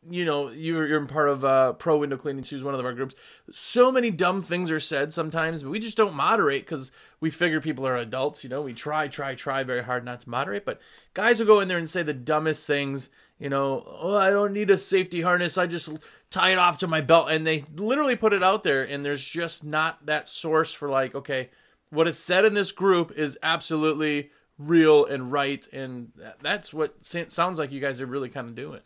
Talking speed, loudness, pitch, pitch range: 230 wpm, -24 LUFS, 155 Hz, 140-175 Hz